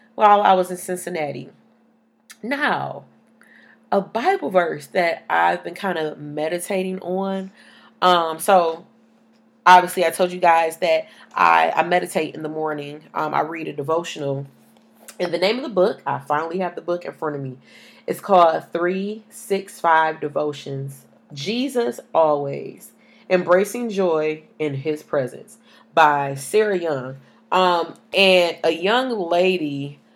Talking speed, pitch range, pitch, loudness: 135 wpm, 150-200 Hz, 175 Hz, -20 LUFS